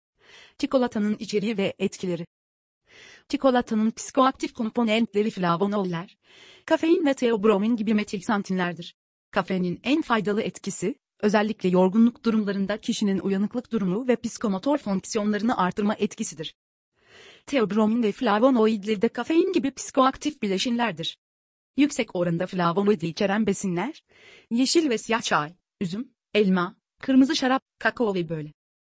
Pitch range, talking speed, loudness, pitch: 195-245 Hz, 110 wpm, -24 LUFS, 215 Hz